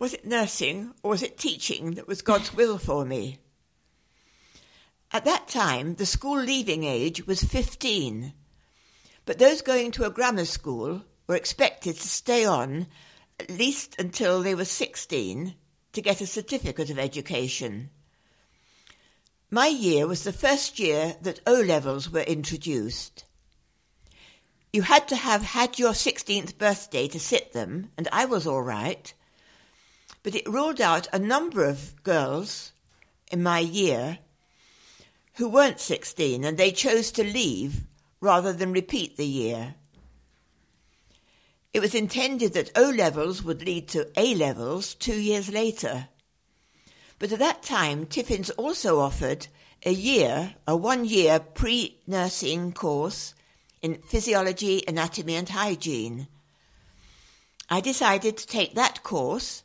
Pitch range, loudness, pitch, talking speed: 150-225 Hz, -26 LUFS, 185 Hz, 140 wpm